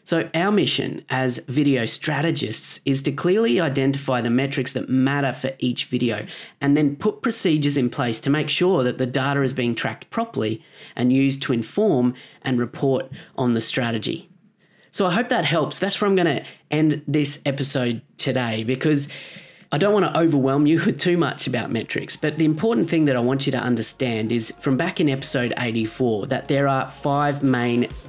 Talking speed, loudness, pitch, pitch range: 190 wpm, -21 LUFS, 140 Hz, 125-160 Hz